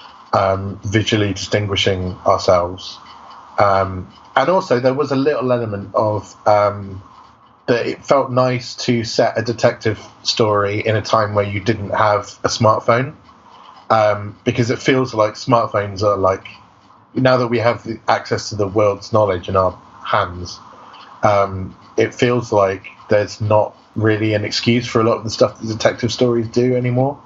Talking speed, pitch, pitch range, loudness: 160 wpm, 110 Hz, 100-120 Hz, -17 LUFS